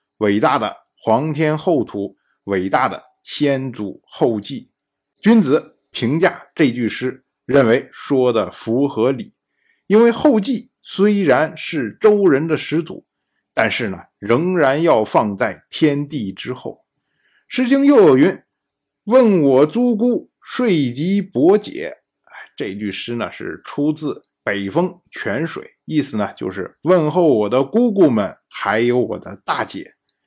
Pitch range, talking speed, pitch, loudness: 120-200 Hz, 190 characters per minute, 150 Hz, -17 LUFS